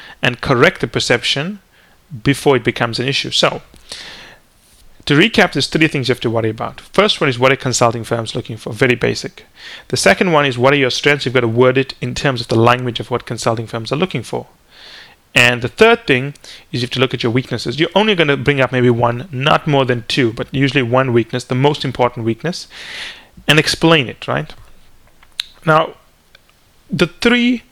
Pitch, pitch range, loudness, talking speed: 130 Hz, 120-145 Hz, -15 LUFS, 205 wpm